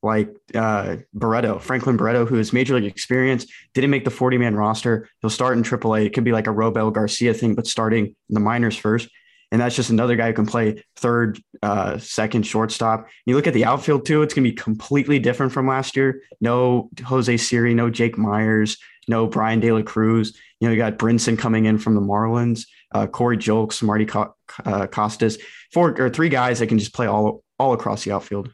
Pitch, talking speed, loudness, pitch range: 115 Hz, 210 wpm, -20 LUFS, 110-125 Hz